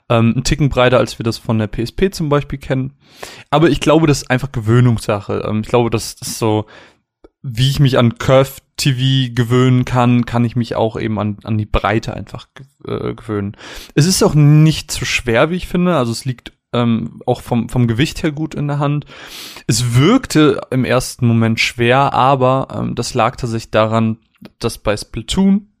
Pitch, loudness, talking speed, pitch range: 125 Hz, -15 LUFS, 180 wpm, 115-140 Hz